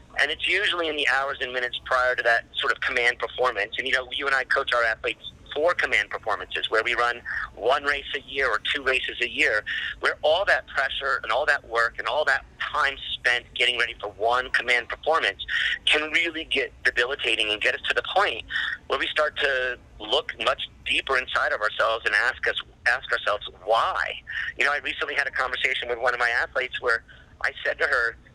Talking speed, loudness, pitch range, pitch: 215 wpm, -24 LUFS, 120-135 Hz, 125 Hz